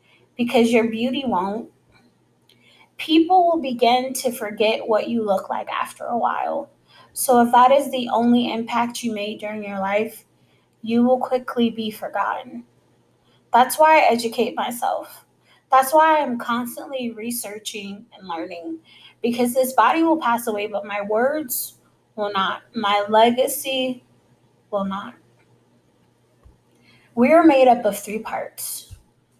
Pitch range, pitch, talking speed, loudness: 210-255 Hz, 235 Hz, 135 wpm, -20 LUFS